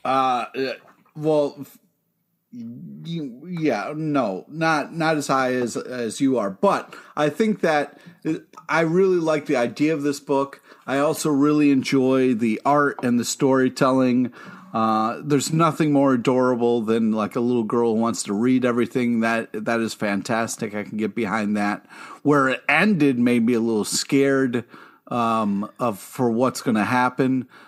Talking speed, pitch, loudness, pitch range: 150 wpm, 130 Hz, -21 LUFS, 120-150 Hz